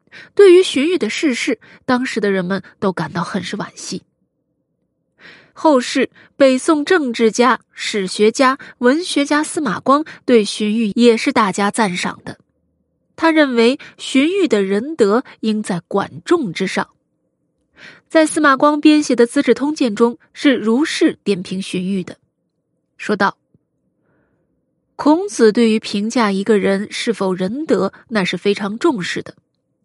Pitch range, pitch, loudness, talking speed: 205-295 Hz, 235 Hz, -16 LUFS, 205 characters per minute